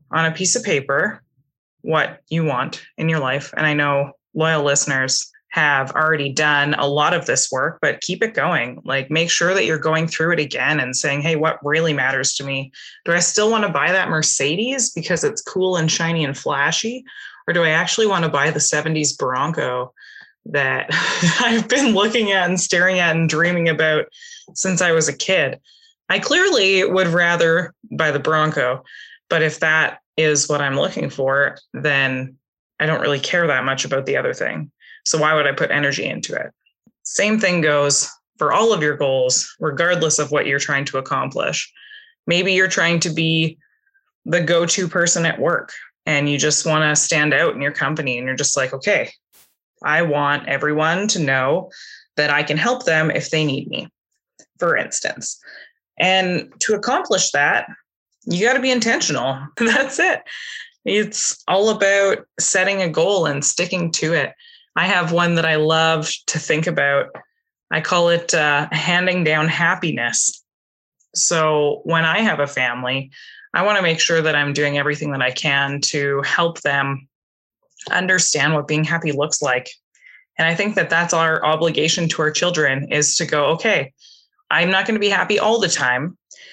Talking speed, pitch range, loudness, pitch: 185 wpm, 145-185 Hz, -18 LUFS, 160 Hz